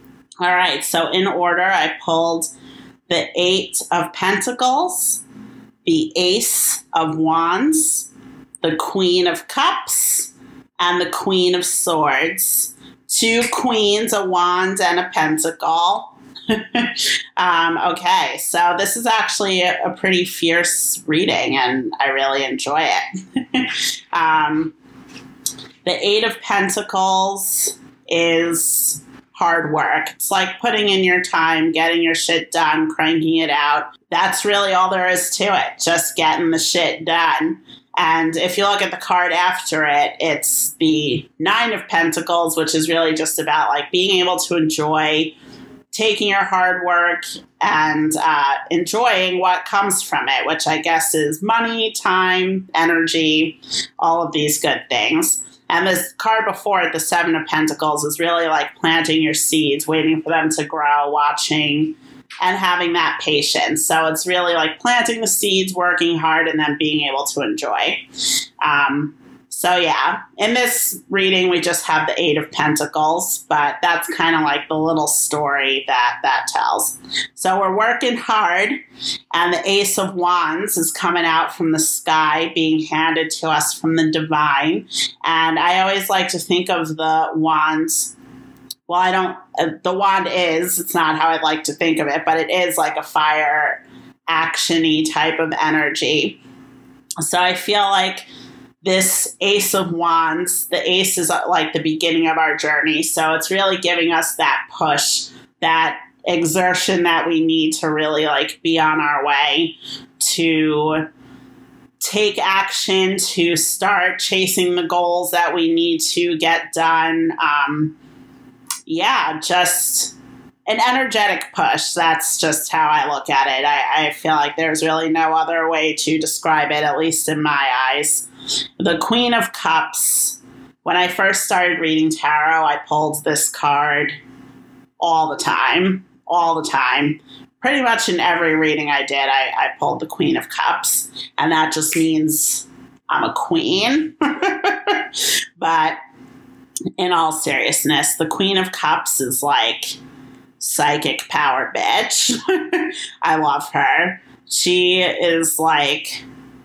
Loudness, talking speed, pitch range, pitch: -17 LUFS, 150 wpm, 155-190 Hz, 170 Hz